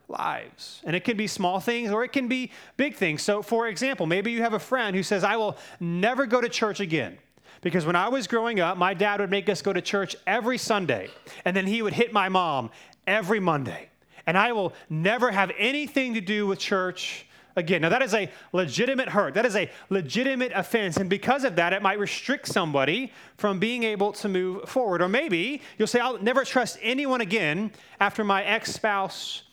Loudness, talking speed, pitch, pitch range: -25 LUFS, 210 wpm, 205 Hz, 190-240 Hz